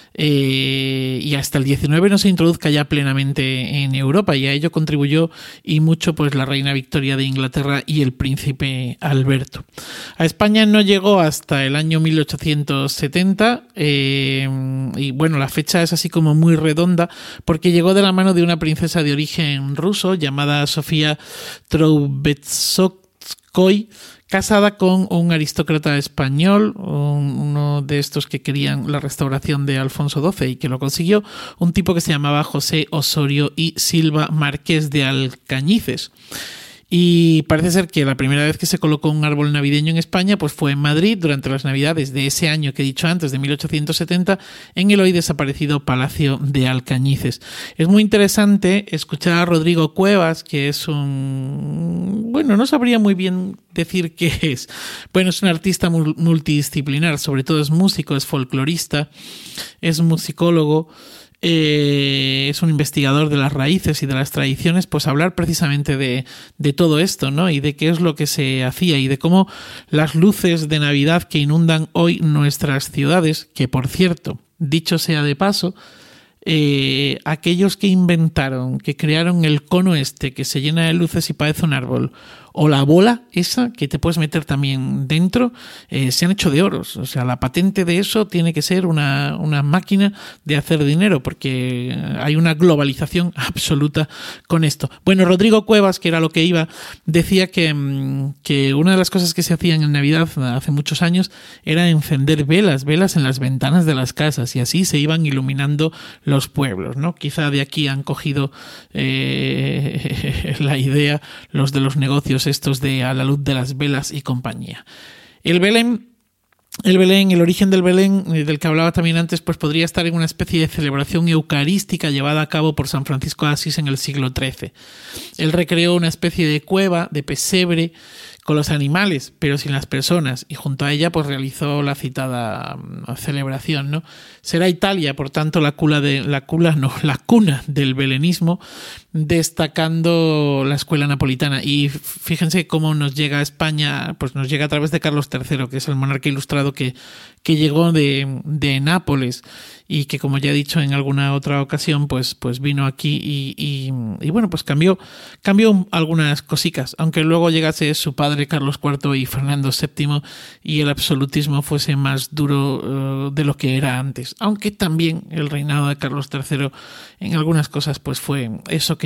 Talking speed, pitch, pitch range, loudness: 175 wpm, 150 Hz, 140-170 Hz, -17 LUFS